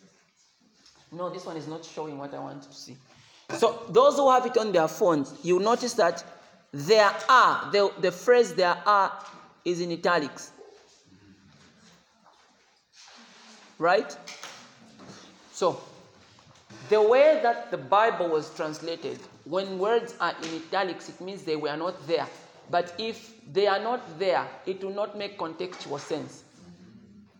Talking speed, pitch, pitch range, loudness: 140 wpm, 185 Hz, 165-215 Hz, -25 LUFS